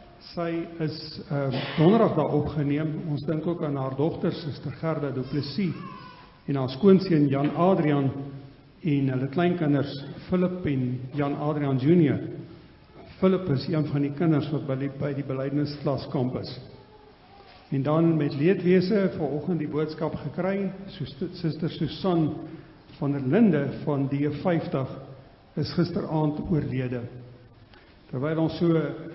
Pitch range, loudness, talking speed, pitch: 140-165 Hz, -26 LUFS, 135 wpm, 150 Hz